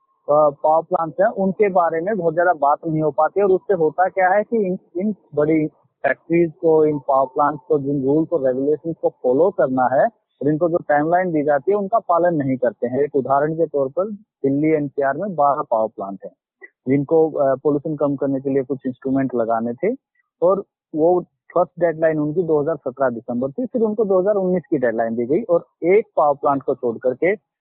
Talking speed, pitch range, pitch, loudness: 200 wpm, 140-185 Hz, 155 Hz, -19 LUFS